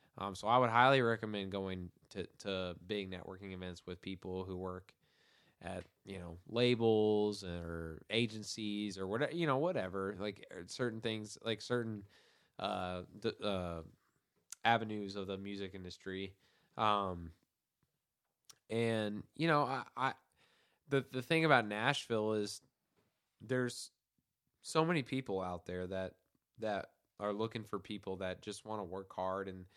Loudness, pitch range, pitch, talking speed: -38 LUFS, 95-115 Hz, 105 Hz, 145 wpm